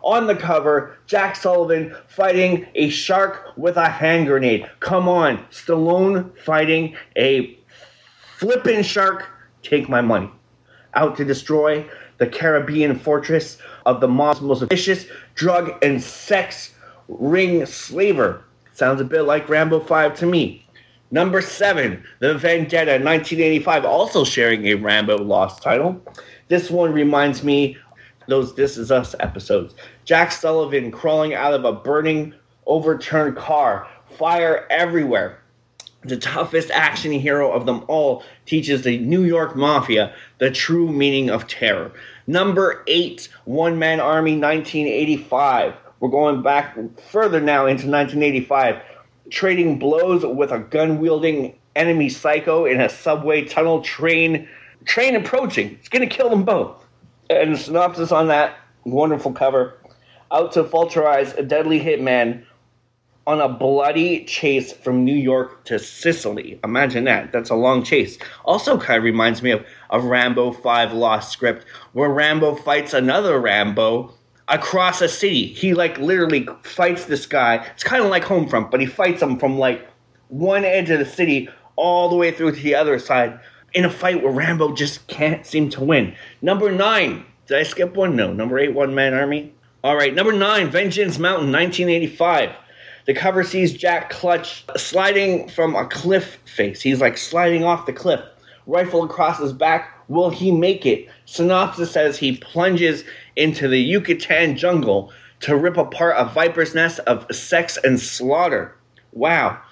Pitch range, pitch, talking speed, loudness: 135-175 Hz, 155 Hz, 150 wpm, -18 LUFS